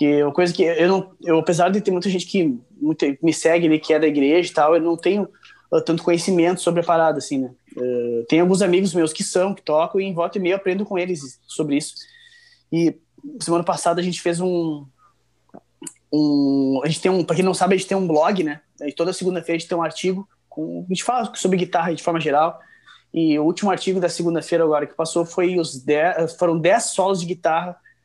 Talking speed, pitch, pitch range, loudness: 230 wpm, 170 Hz, 155-185 Hz, -20 LUFS